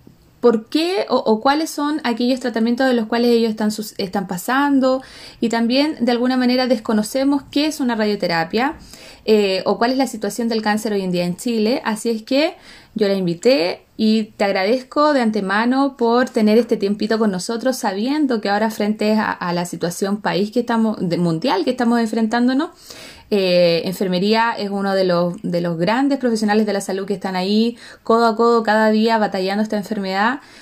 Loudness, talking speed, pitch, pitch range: -18 LUFS, 185 wpm, 225 Hz, 200-245 Hz